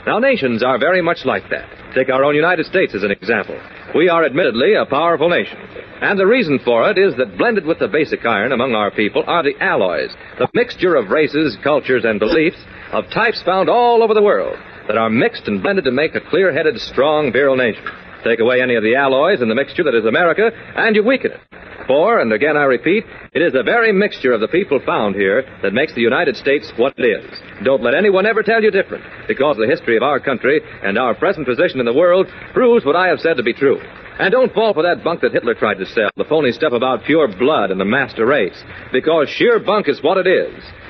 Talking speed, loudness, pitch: 235 wpm, -15 LUFS, 215 Hz